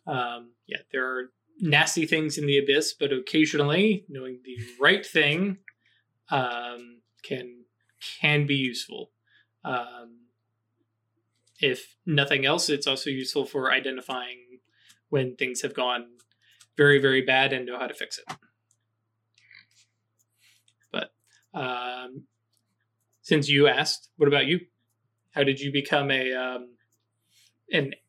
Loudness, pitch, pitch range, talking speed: -25 LUFS, 125 Hz, 115-145 Hz, 120 wpm